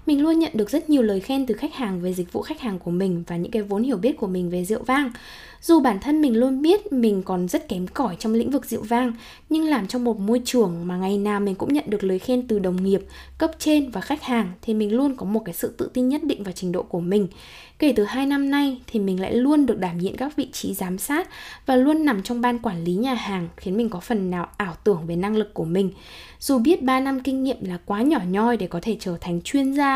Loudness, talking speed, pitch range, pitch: -23 LUFS, 280 wpm, 190-275 Hz, 230 Hz